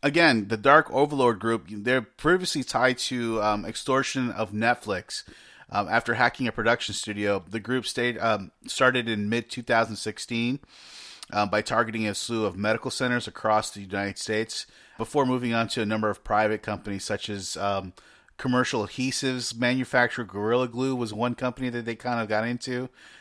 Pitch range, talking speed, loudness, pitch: 105-125 Hz, 170 wpm, -26 LUFS, 115 Hz